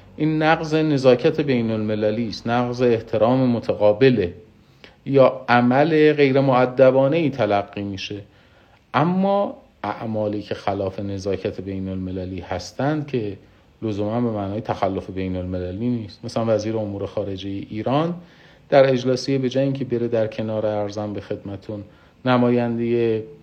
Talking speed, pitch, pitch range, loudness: 125 wpm, 115 Hz, 100-130 Hz, -21 LUFS